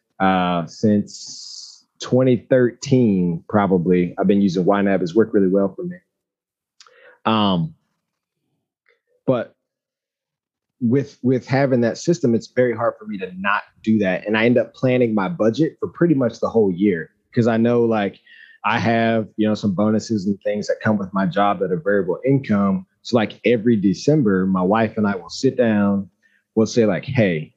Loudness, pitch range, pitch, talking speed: -19 LUFS, 100-125 Hz, 110 Hz, 170 wpm